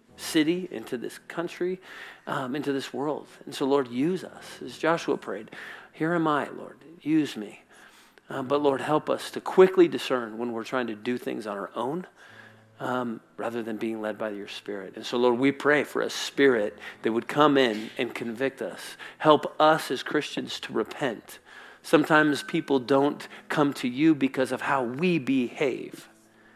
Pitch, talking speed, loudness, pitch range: 140 Hz, 180 wpm, -26 LUFS, 120-160 Hz